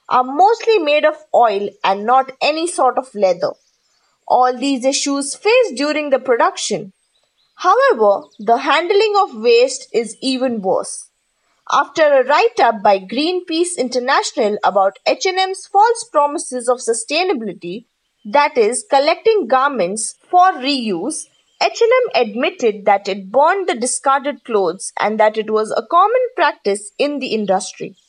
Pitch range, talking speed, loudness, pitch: 230-360 Hz, 135 wpm, -16 LUFS, 275 Hz